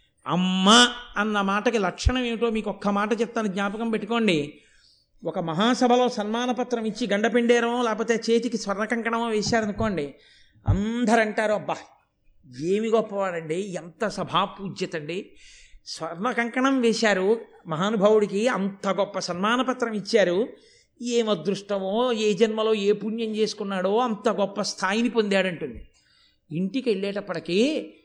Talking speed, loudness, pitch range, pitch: 105 wpm, -24 LUFS, 195-235 Hz, 215 Hz